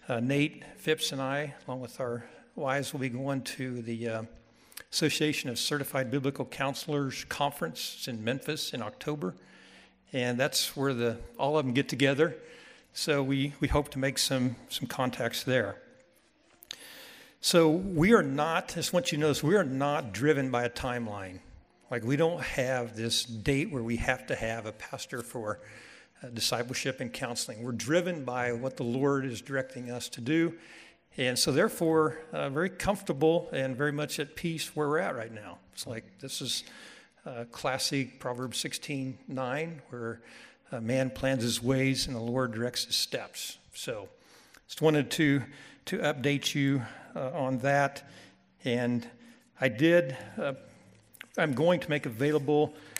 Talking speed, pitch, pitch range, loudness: 170 wpm, 135 Hz, 125-150 Hz, -30 LUFS